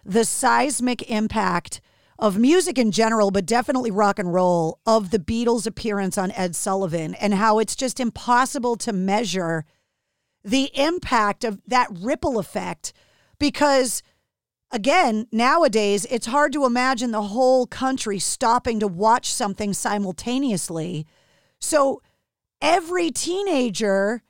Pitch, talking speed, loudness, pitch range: 225 Hz, 125 wpm, -21 LUFS, 200-255 Hz